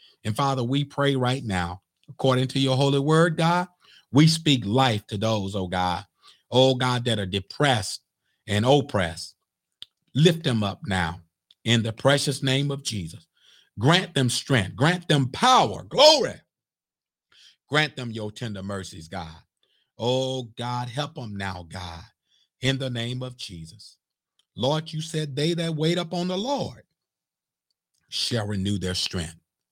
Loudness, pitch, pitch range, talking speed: -24 LUFS, 125 Hz, 95-140 Hz, 145 wpm